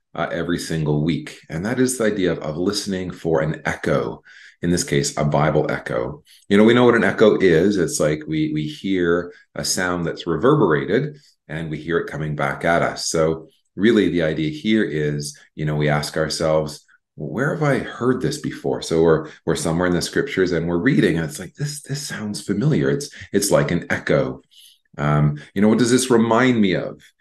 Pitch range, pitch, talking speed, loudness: 75-105 Hz, 85 Hz, 210 wpm, -20 LUFS